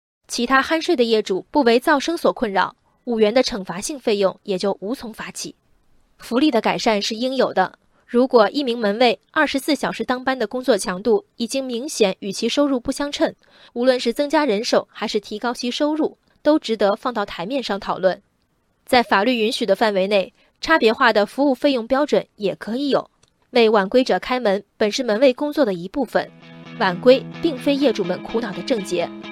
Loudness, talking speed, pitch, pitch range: -20 LUFS, 290 characters per minute, 235 Hz, 200-265 Hz